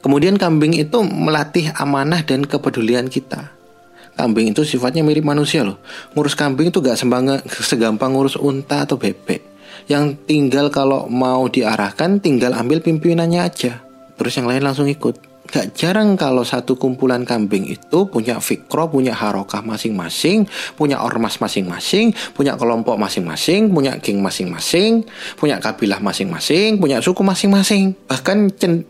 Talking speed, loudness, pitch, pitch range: 140 wpm, -17 LUFS, 140 Hz, 125-165 Hz